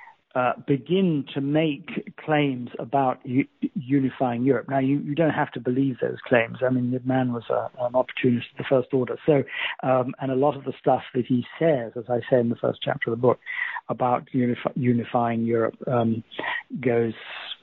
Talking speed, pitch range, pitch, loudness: 195 wpm, 125-145 Hz, 130 Hz, -25 LUFS